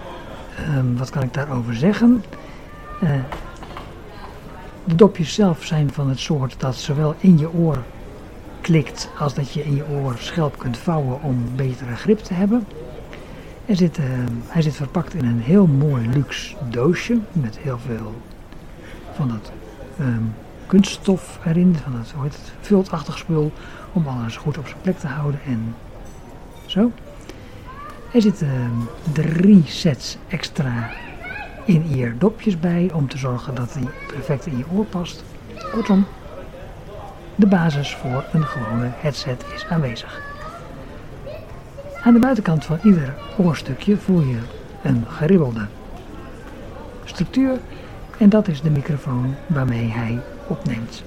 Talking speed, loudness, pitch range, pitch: 135 wpm, -20 LUFS, 125-175 Hz, 145 Hz